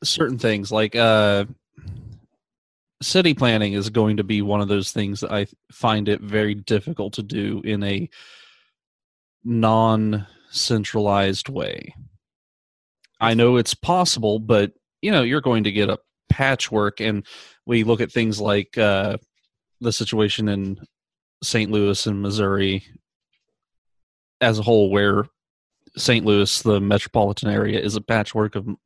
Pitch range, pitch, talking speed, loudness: 100-115 Hz, 105 Hz, 140 wpm, -20 LUFS